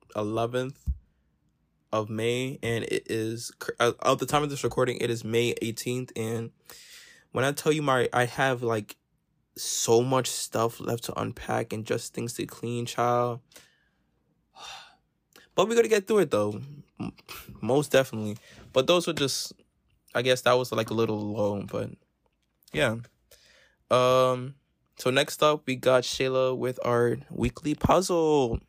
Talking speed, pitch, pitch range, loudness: 150 wpm, 125 Hz, 115-135 Hz, -27 LUFS